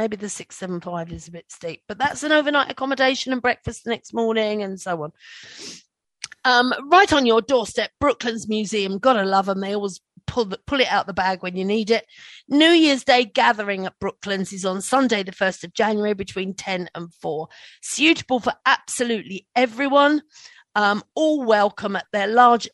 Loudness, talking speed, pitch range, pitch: -20 LUFS, 190 wpm, 195-255 Hz, 215 Hz